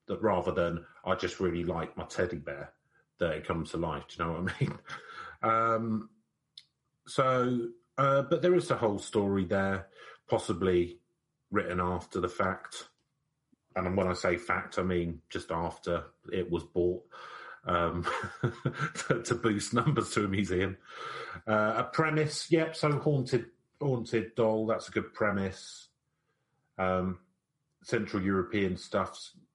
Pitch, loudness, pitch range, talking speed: 110 Hz, -31 LUFS, 95-125 Hz, 145 wpm